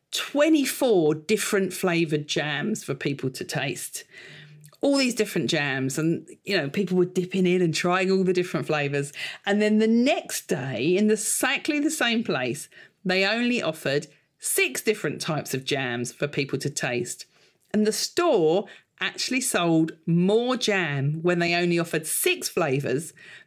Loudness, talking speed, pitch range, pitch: -24 LUFS, 155 wpm, 150-215 Hz, 180 Hz